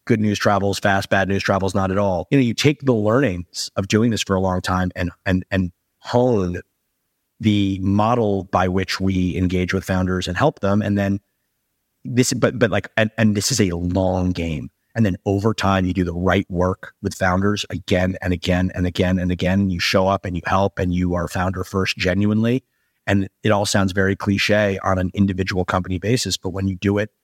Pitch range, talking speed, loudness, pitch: 90-105 Hz, 215 wpm, -20 LUFS, 95 Hz